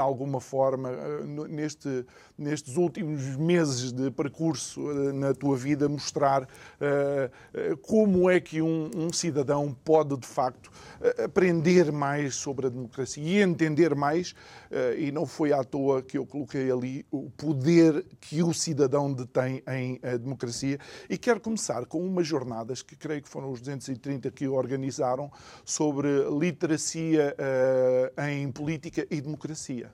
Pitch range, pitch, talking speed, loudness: 135-160 Hz, 145 Hz, 145 wpm, -28 LUFS